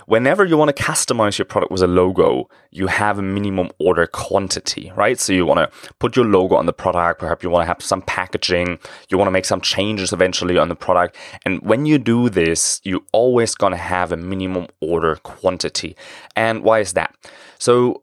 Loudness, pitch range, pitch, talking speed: -18 LUFS, 90-115 Hz, 95 Hz, 210 wpm